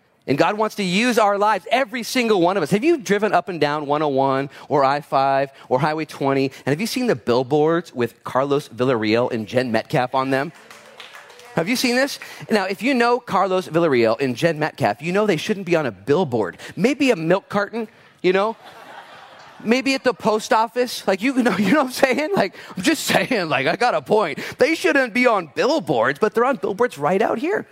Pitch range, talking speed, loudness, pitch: 140-235 Hz, 215 wpm, -20 LUFS, 185 Hz